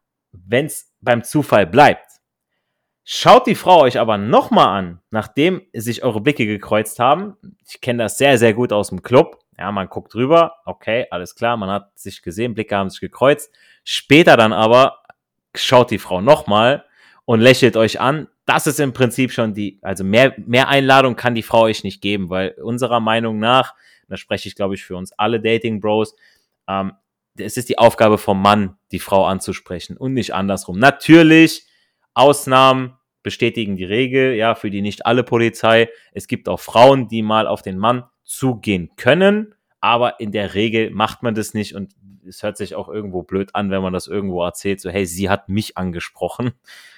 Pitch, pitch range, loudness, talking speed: 110 Hz, 100-125 Hz, -16 LUFS, 185 wpm